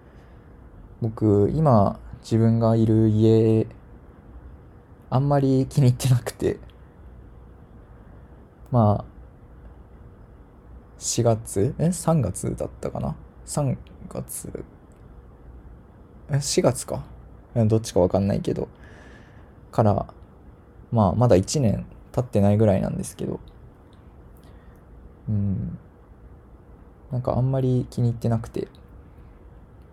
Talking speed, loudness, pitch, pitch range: 170 characters per minute, -23 LUFS, 110 Hz, 95-125 Hz